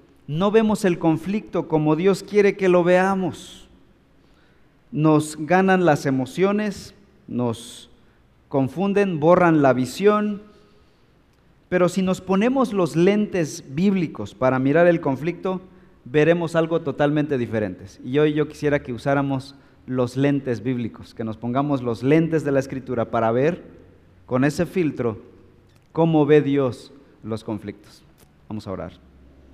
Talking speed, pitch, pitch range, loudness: 130 wpm, 145 Hz, 120-180 Hz, -21 LUFS